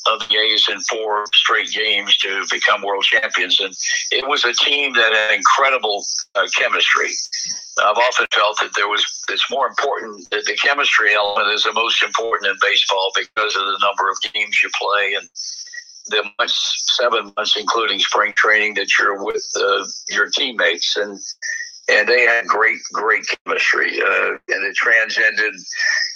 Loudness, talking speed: -16 LUFS, 165 wpm